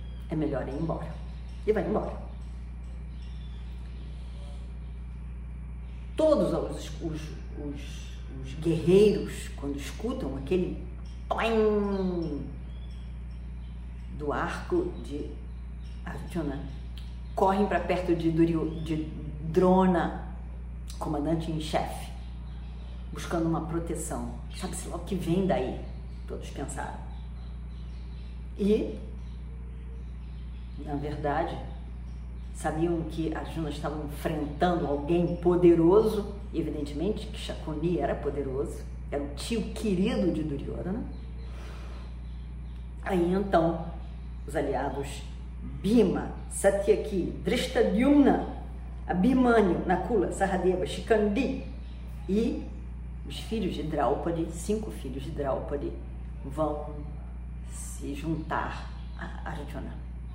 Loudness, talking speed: -29 LUFS, 85 wpm